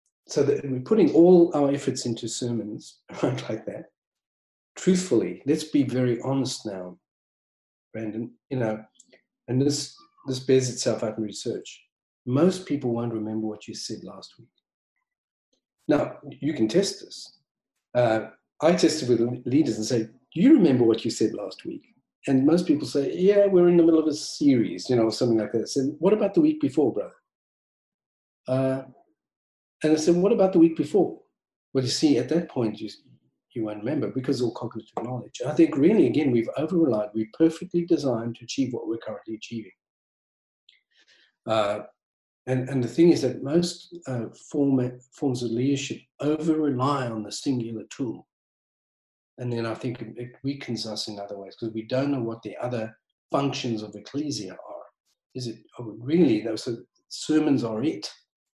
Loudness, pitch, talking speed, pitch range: -25 LUFS, 130 Hz, 180 wpm, 115-155 Hz